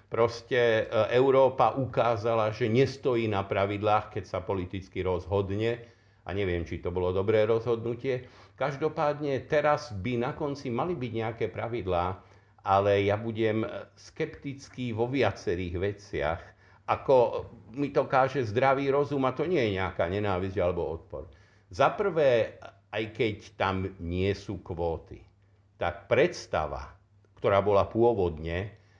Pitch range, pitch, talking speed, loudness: 100-125 Hz, 110 Hz, 125 wpm, -28 LUFS